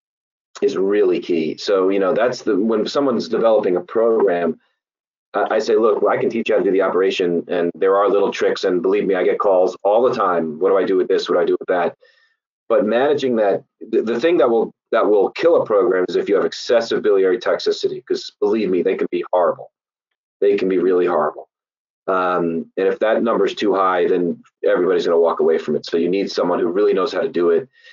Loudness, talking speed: -18 LUFS, 235 wpm